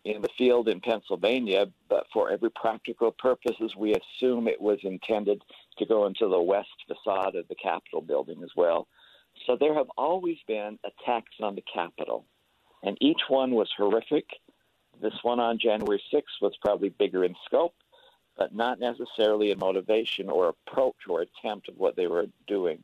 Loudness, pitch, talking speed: -28 LUFS, 130 Hz, 170 wpm